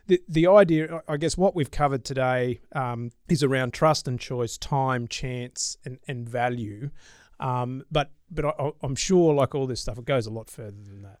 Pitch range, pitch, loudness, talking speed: 125-150 Hz, 135 Hz, -25 LUFS, 200 wpm